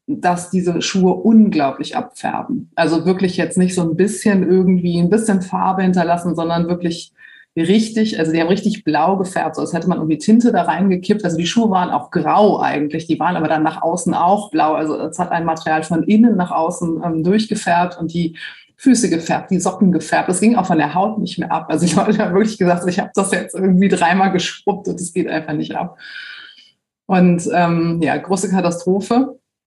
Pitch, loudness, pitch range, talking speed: 180 Hz, -16 LUFS, 170-200 Hz, 200 wpm